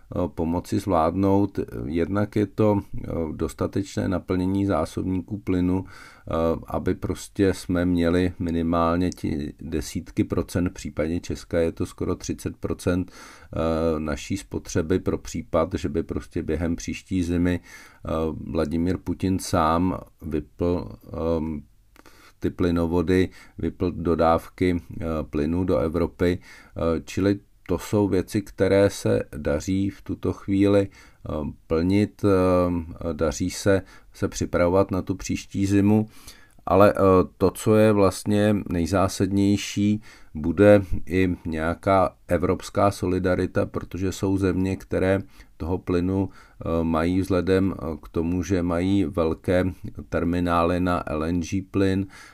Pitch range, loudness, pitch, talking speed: 85-100 Hz, -24 LUFS, 90 Hz, 105 wpm